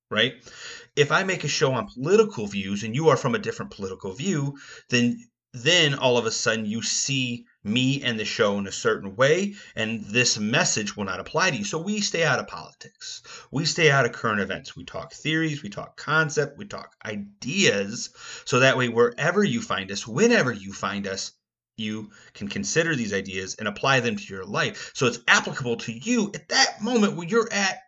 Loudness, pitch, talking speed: -24 LUFS, 140 Hz, 205 wpm